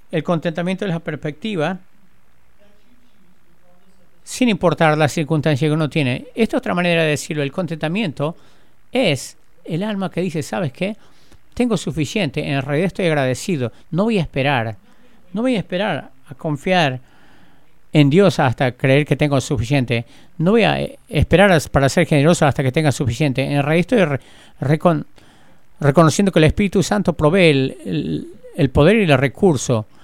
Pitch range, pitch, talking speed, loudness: 145-180 Hz, 155 Hz, 160 wpm, -18 LUFS